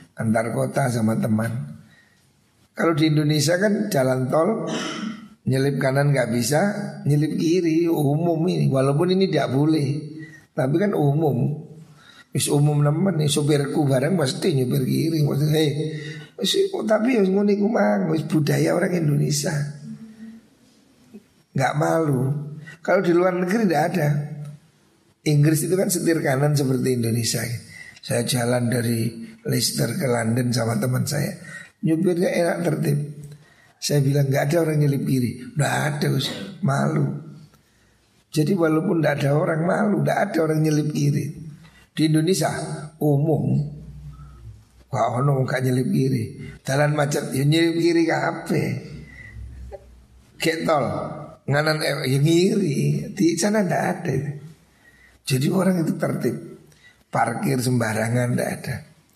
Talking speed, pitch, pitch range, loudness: 120 wpm, 150 Hz, 135-170 Hz, -22 LUFS